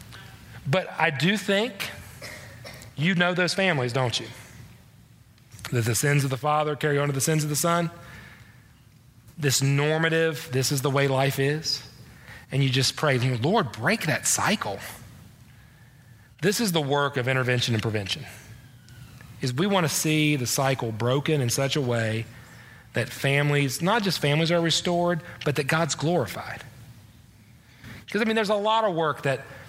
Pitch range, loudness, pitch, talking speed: 120-155 Hz, -24 LUFS, 135 Hz, 160 wpm